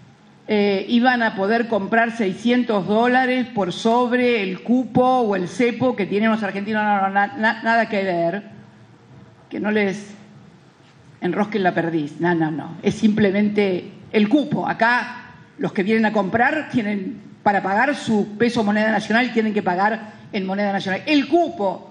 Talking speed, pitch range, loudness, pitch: 160 wpm, 195-235 Hz, -20 LUFS, 210 Hz